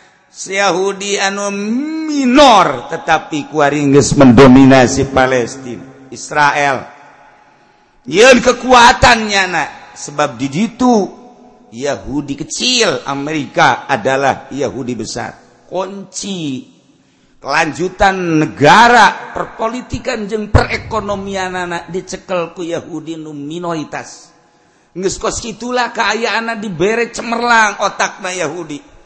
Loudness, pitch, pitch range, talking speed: -12 LUFS, 180 Hz, 145-220 Hz, 85 wpm